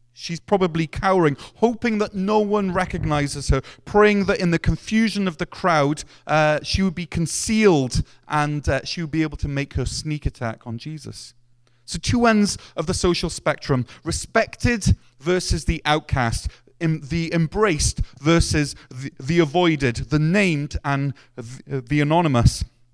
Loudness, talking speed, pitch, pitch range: -21 LUFS, 155 wpm, 150 Hz, 135-180 Hz